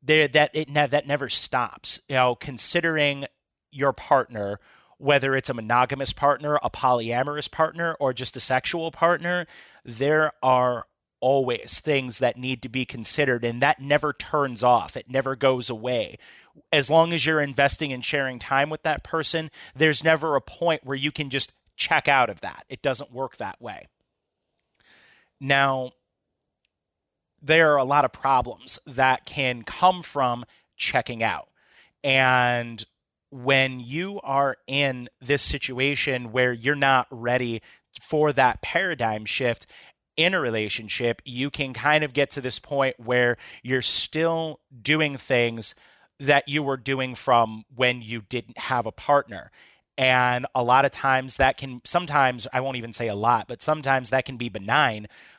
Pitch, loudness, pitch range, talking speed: 135 Hz, -23 LUFS, 125-145 Hz, 160 wpm